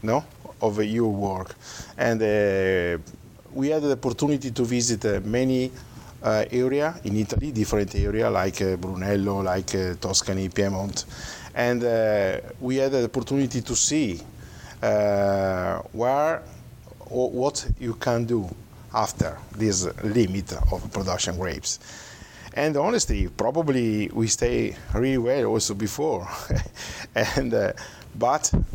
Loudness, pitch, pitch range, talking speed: -25 LUFS, 110 Hz, 100-125 Hz, 125 wpm